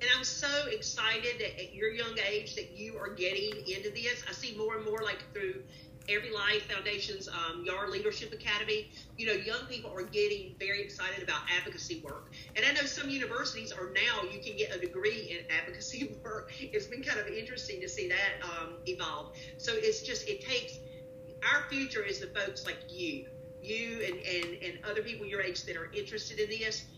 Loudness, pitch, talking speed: -34 LUFS, 225 Hz, 200 wpm